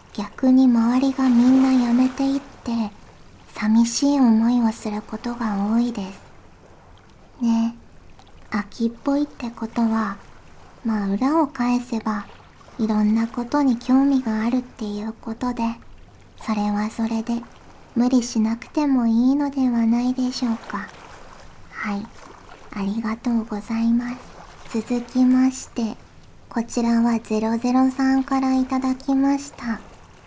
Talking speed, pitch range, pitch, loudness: 245 characters per minute, 225-255 Hz, 235 Hz, -22 LUFS